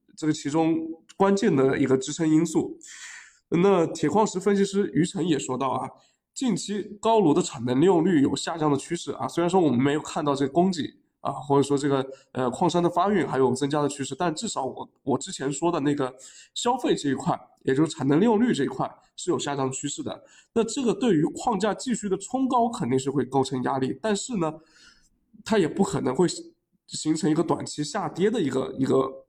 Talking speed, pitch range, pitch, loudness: 310 characters per minute, 140-205 Hz, 160 Hz, -25 LUFS